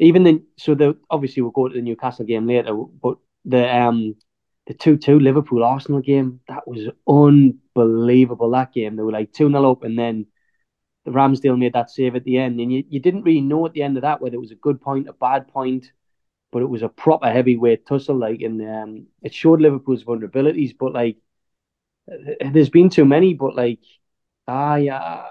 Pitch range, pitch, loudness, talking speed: 120-145 Hz, 130 Hz, -18 LUFS, 205 wpm